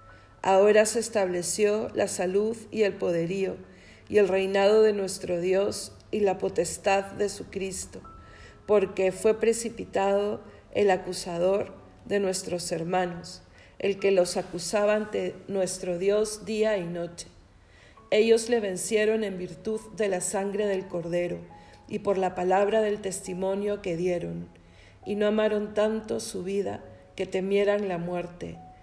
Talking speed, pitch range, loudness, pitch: 135 wpm, 175-210 Hz, -27 LUFS, 190 Hz